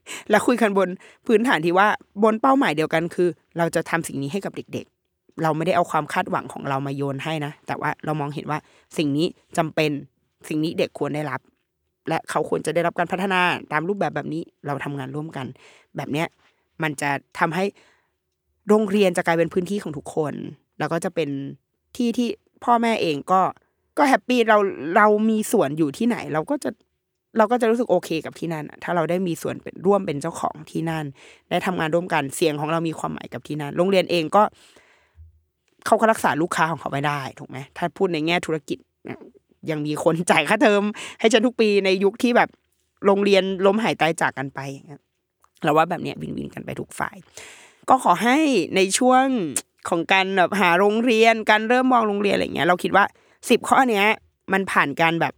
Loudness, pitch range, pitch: -21 LUFS, 155-205 Hz, 175 Hz